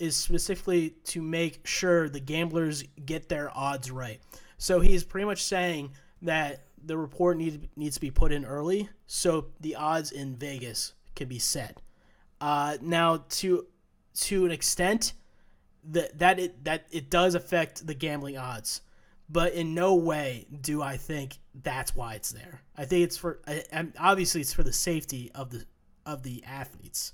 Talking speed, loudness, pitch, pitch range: 165 wpm, -29 LUFS, 155 Hz, 140-170 Hz